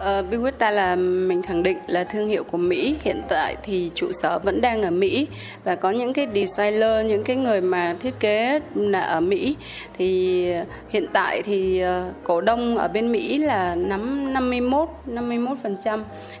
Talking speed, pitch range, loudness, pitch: 180 wpm, 185-255 Hz, -22 LUFS, 215 Hz